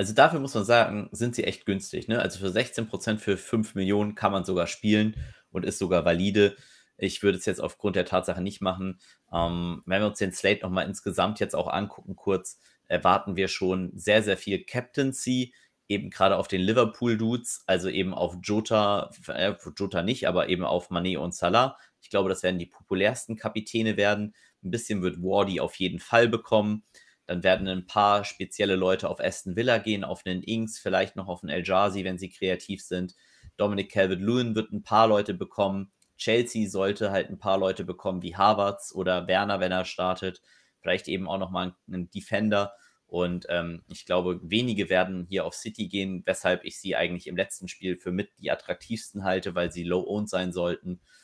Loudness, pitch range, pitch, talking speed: -27 LUFS, 90-105 Hz, 95 Hz, 190 wpm